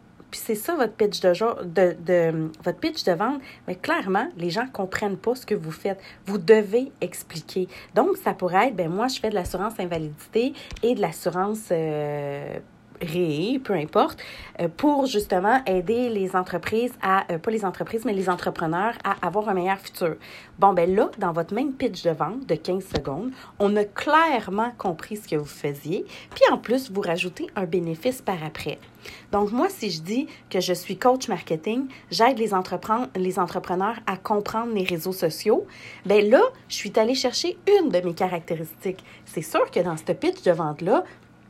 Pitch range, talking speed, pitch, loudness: 180-230 Hz, 185 wpm, 195 Hz, -24 LUFS